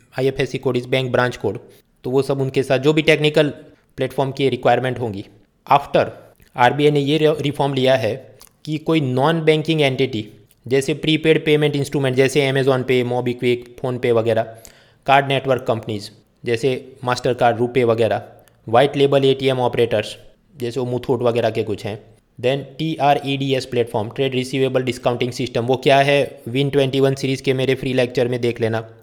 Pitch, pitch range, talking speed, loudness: 130 Hz, 120-140 Hz, 175 wpm, -19 LUFS